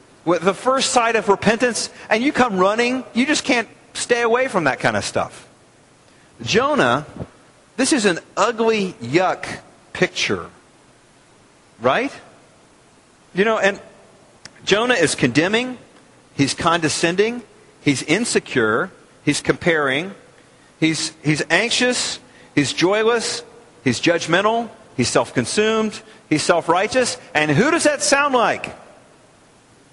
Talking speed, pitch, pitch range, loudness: 115 wpm, 210 Hz, 160-235 Hz, -19 LUFS